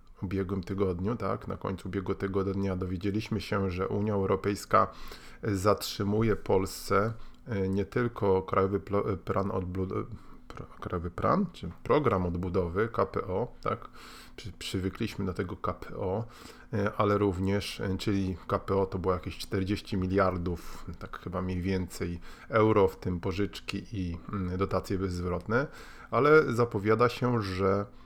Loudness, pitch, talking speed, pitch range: -30 LUFS, 95 Hz, 115 wpm, 95-105 Hz